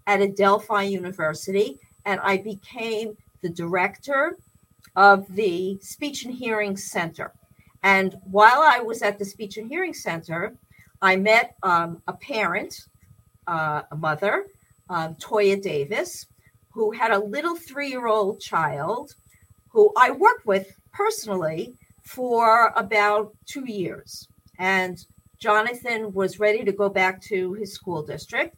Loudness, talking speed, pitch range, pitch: -22 LUFS, 130 wpm, 185-225 Hz, 200 Hz